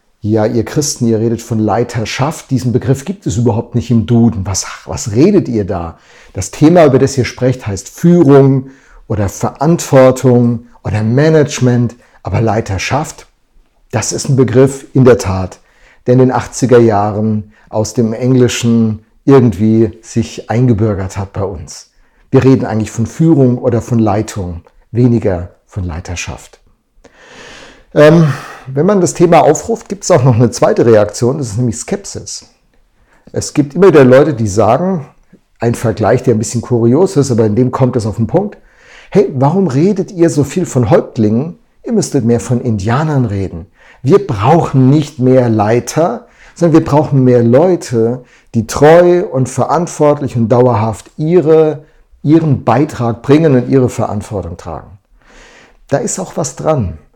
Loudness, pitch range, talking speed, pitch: -11 LUFS, 110-145 Hz, 155 wpm, 125 Hz